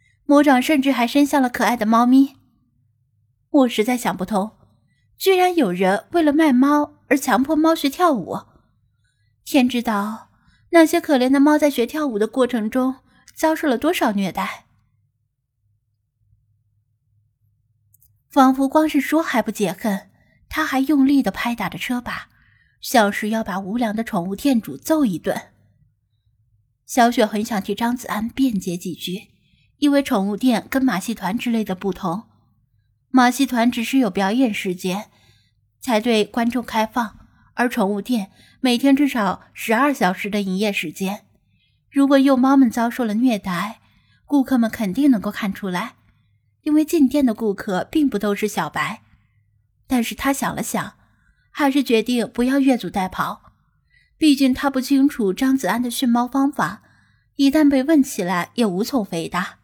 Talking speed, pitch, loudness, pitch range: 225 characters per minute, 230 Hz, -19 LUFS, 185-270 Hz